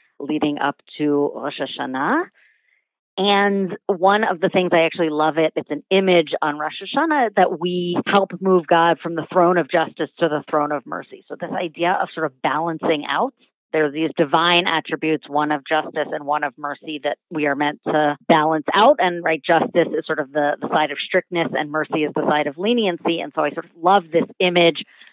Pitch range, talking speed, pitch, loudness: 150-180 Hz, 210 wpm, 165 Hz, -20 LUFS